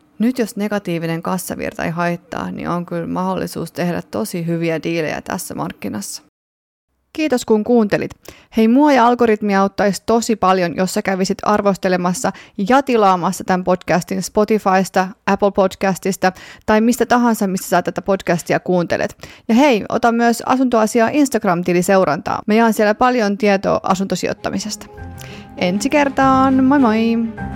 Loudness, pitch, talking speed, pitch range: -17 LUFS, 195 Hz, 135 wpm, 180-230 Hz